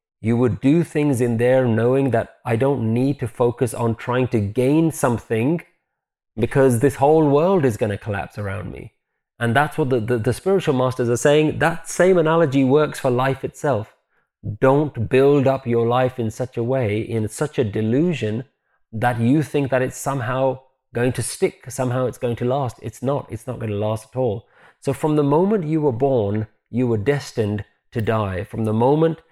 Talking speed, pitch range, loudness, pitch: 195 wpm, 115-145 Hz, -20 LUFS, 130 Hz